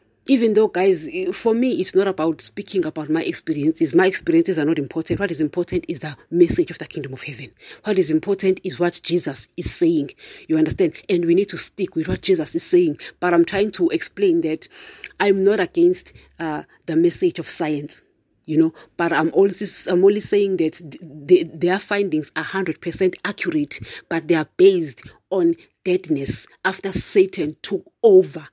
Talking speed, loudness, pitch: 185 wpm, -20 LUFS, 190 Hz